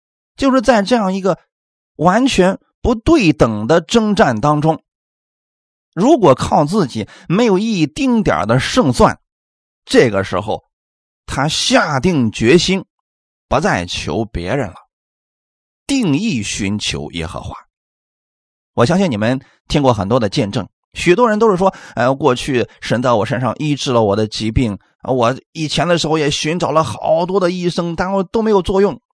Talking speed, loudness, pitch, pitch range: 220 characters per minute, -15 LUFS, 165 Hz, 115-195 Hz